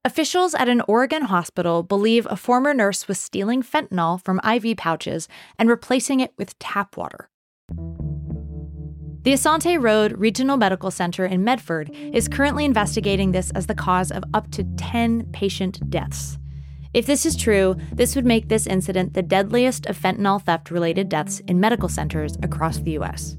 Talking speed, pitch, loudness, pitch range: 165 wpm, 195 Hz, -21 LUFS, 165-235 Hz